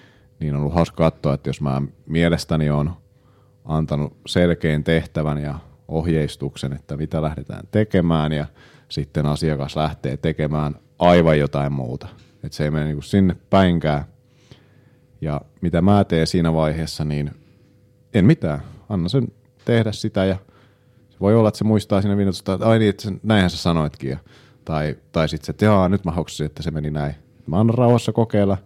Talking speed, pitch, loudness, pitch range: 170 wpm, 85 Hz, -20 LUFS, 75-100 Hz